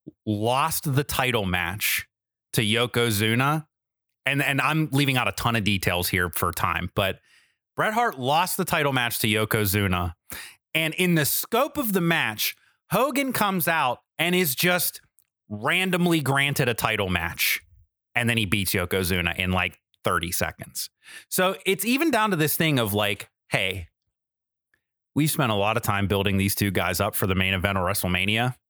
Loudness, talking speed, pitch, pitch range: -23 LUFS, 170 wpm, 115 Hz, 100-155 Hz